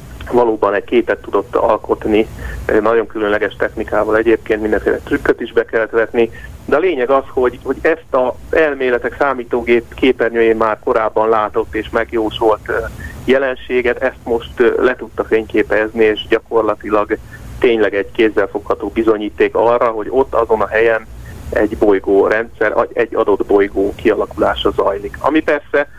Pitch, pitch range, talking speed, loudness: 120 Hz, 110-170 Hz, 135 wpm, -15 LUFS